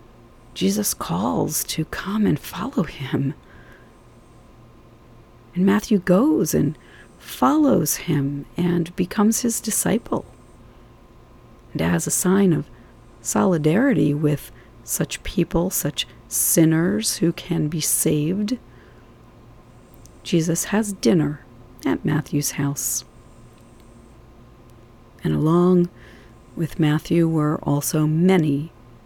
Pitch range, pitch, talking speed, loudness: 120-175 Hz, 150 Hz, 95 wpm, -21 LUFS